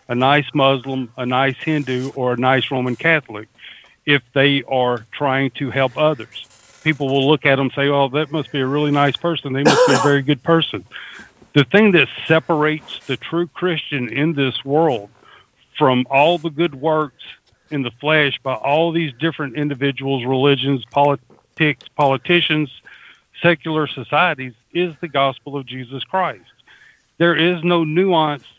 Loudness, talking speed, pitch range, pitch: -18 LUFS, 165 wpm, 130-155 Hz, 140 Hz